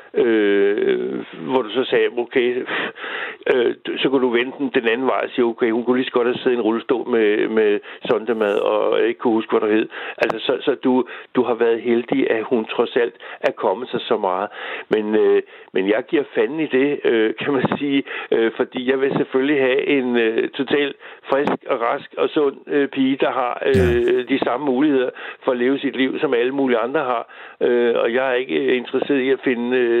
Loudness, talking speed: -19 LUFS, 220 wpm